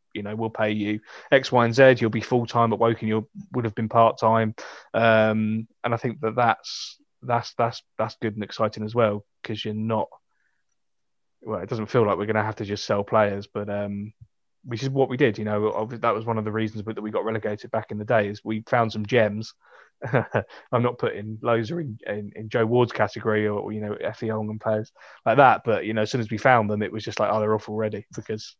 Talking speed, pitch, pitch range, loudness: 245 wpm, 110 Hz, 105-115 Hz, -24 LUFS